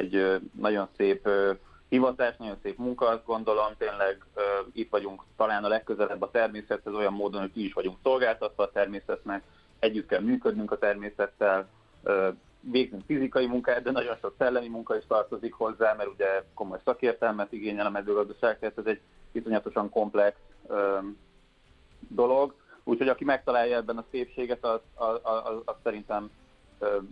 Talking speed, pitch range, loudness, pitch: 145 wpm, 100-115 Hz, -29 LUFS, 105 Hz